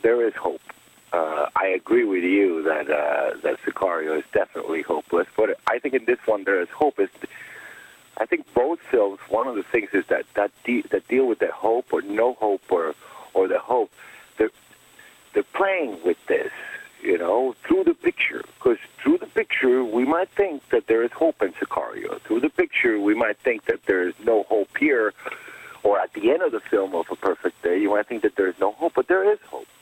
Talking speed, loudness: 215 wpm, -23 LUFS